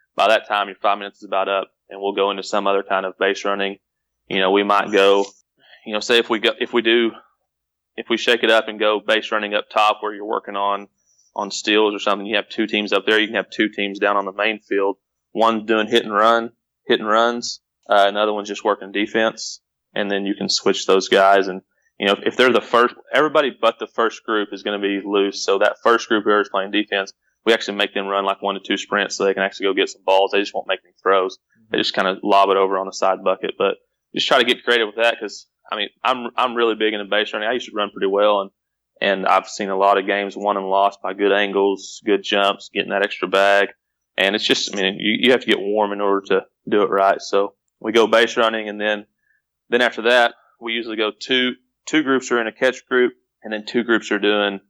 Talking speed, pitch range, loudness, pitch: 260 wpm, 100-110 Hz, -19 LUFS, 100 Hz